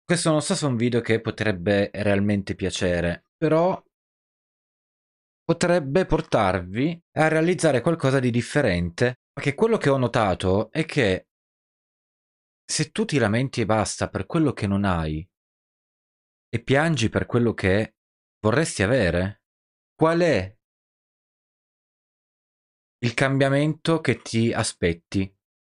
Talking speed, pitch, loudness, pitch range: 120 wpm, 115 Hz, -23 LUFS, 95-150 Hz